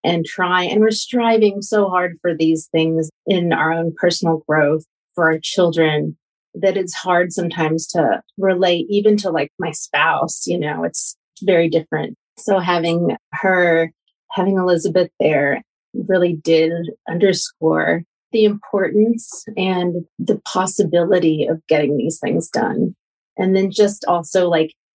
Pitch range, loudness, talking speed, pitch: 165-195 Hz, -18 LUFS, 140 wpm, 180 Hz